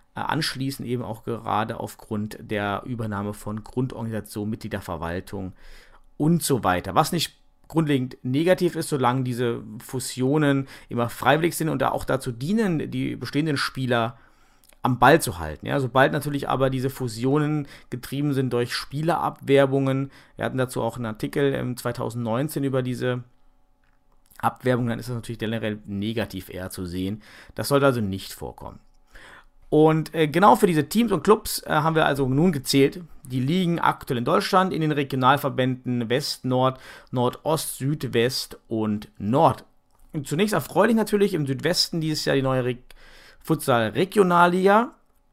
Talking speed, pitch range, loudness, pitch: 150 wpm, 115-150 Hz, -24 LUFS, 130 Hz